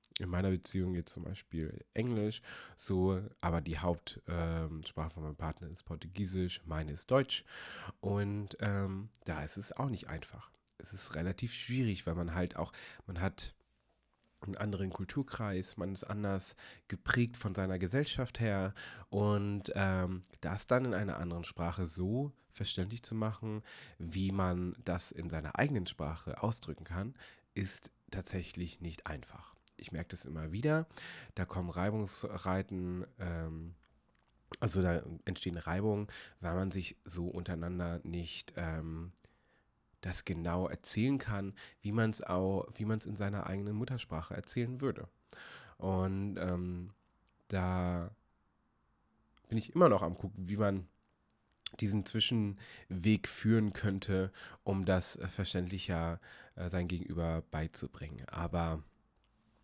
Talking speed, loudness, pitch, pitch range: 130 wpm, -37 LUFS, 95 Hz, 85-105 Hz